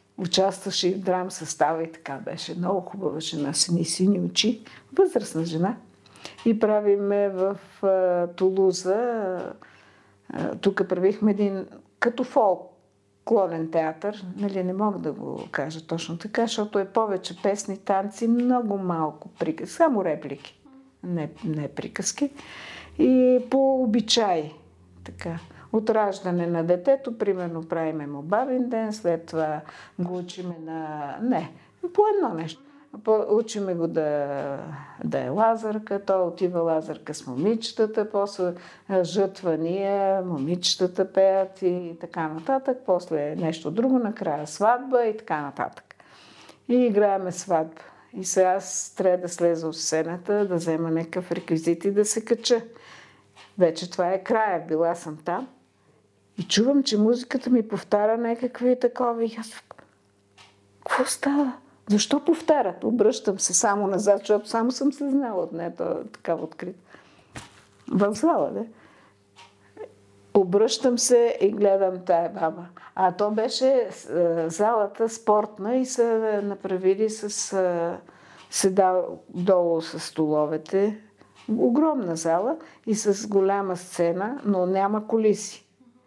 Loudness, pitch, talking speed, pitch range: -24 LUFS, 195 Hz, 125 wpm, 170-225 Hz